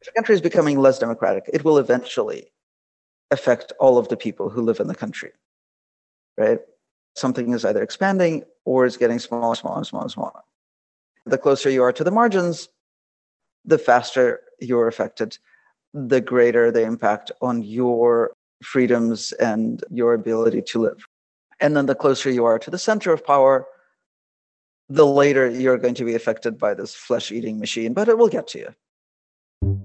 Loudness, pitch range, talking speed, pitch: -20 LUFS, 115-170 Hz, 165 wpm, 130 Hz